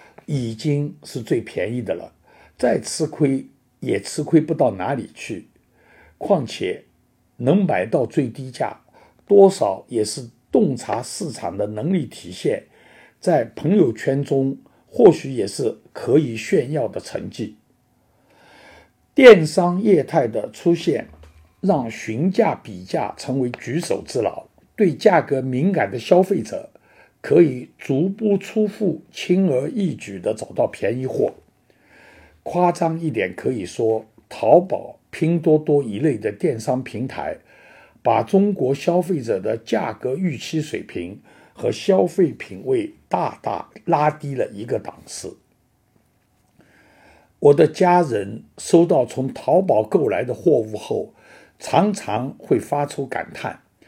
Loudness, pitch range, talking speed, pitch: -20 LUFS, 130-185 Hz, 185 characters per minute, 155 Hz